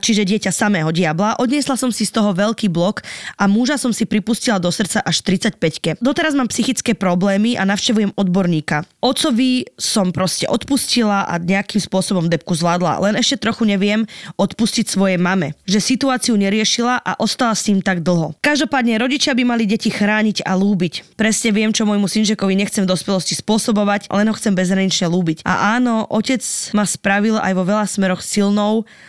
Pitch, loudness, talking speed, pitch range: 210 Hz, -17 LUFS, 175 wpm, 190-225 Hz